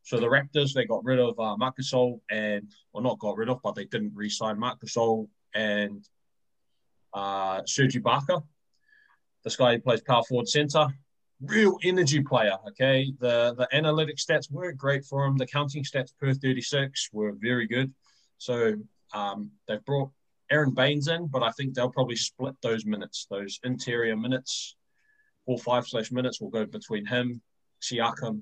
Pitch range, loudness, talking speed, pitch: 115-140 Hz, -27 LUFS, 170 wpm, 125 Hz